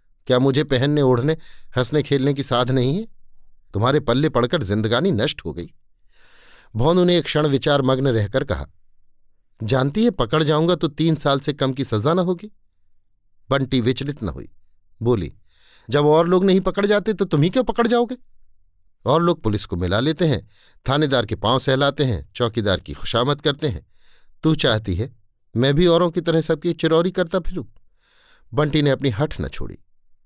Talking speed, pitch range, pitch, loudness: 180 wpm, 110-160 Hz, 135 Hz, -20 LUFS